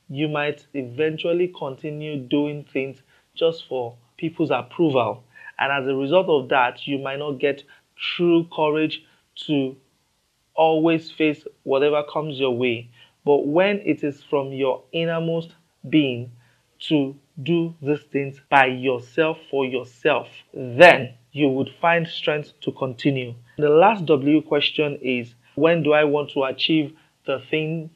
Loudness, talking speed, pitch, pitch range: -21 LUFS, 140 wpm, 145 Hz, 135-160 Hz